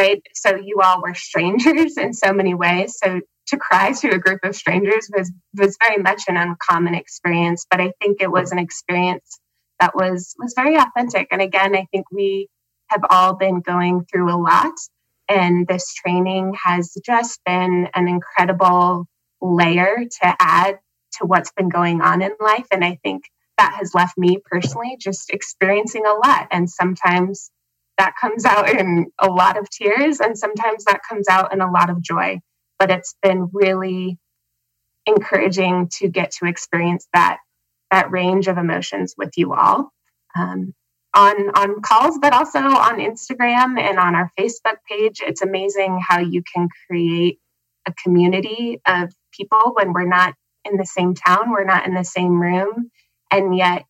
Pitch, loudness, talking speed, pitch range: 185 Hz, -17 LUFS, 170 wpm, 175-200 Hz